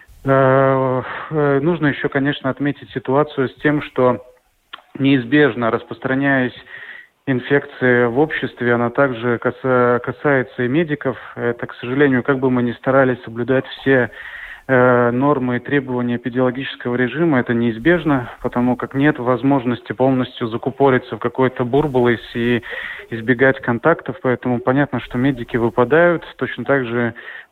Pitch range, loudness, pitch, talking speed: 120-140 Hz, -18 LUFS, 130 Hz, 120 wpm